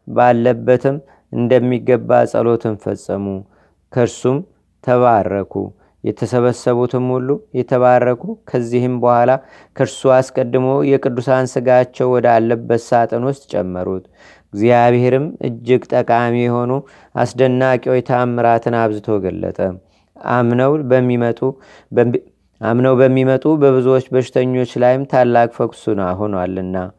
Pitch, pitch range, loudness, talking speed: 125 Hz, 115-130 Hz, -15 LUFS, 80 wpm